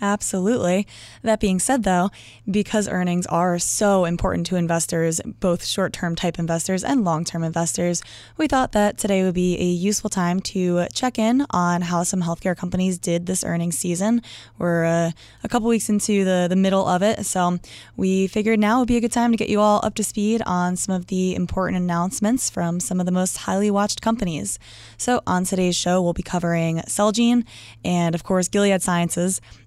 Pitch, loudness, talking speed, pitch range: 185 Hz, -21 LUFS, 190 wpm, 175-210 Hz